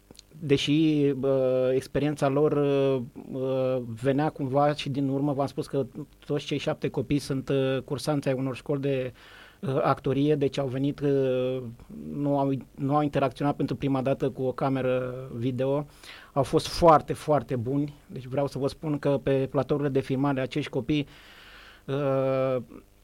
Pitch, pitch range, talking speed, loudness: 140 Hz, 130-145 Hz, 160 wpm, -27 LUFS